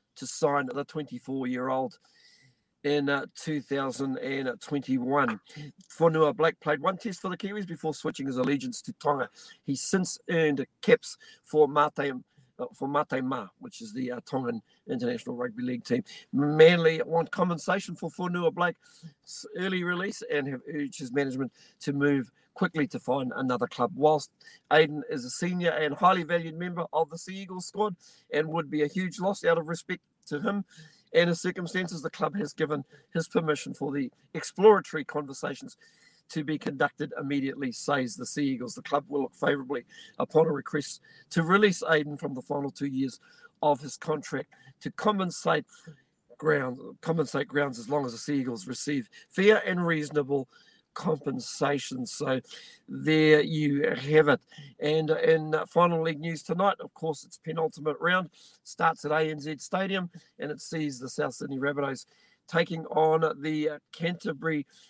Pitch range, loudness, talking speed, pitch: 145-180 Hz, -29 LUFS, 160 wpm, 155 Hz